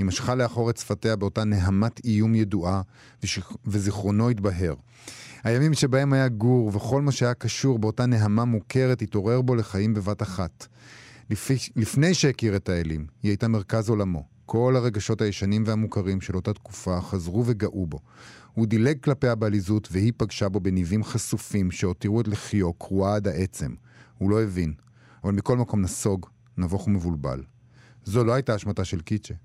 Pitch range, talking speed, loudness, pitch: 100-120 Hz, 155 wpm, -25 LUFS, 110 Hz